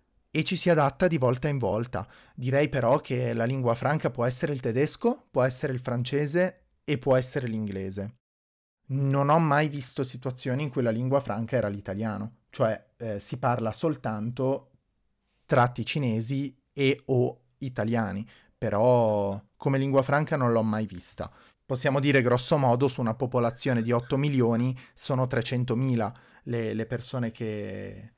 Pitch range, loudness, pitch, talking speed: 115-140 Hz, -27 LUFS, 125 Hz, 155 wpm